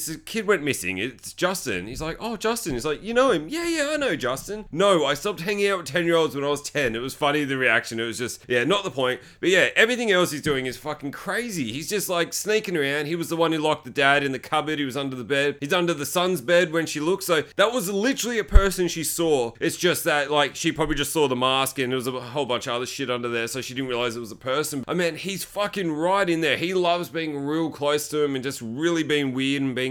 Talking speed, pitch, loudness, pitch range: 285 wpm, 155 Hz, -24 LUFS, 135-180 Hz